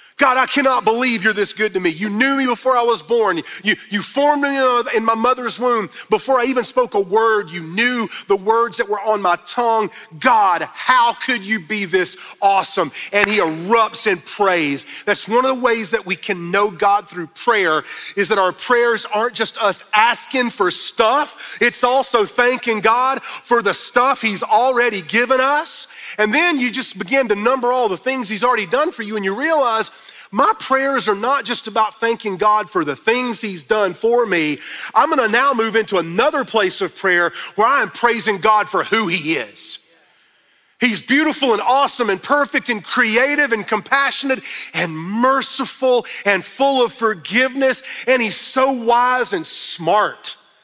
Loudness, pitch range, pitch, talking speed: -17 LUFS, 210-260 Hz, 230 Hz, 185 wpm